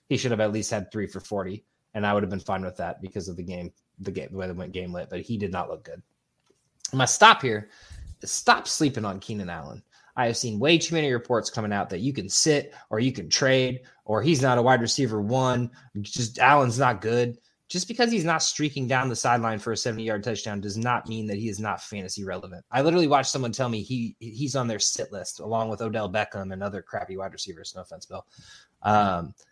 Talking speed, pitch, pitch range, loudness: 240 wpm, 110 Hz, 100-130 Hz, -25 LUFS